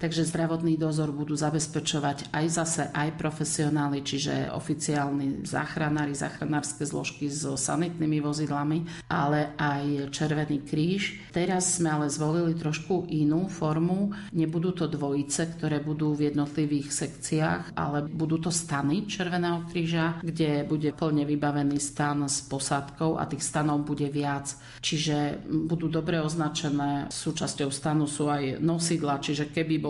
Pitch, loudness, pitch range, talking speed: 150 Hz, -28 LUFS, 145-165 Hz, 130 wpm